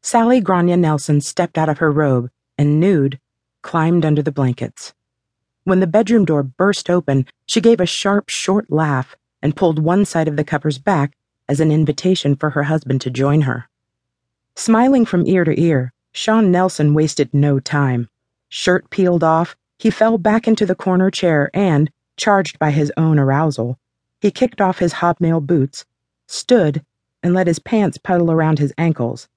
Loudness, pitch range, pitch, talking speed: -16 LUFS, 145-185 Hz, 160 Hz, 170 wpm